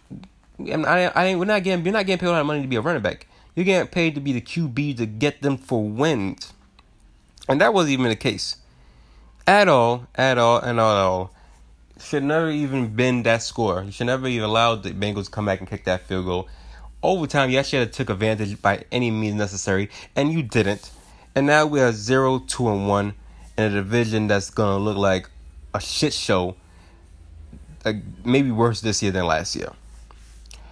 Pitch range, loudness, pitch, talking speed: 90-130 Hz, -21 LUFS, 110 Hz, 205 wpm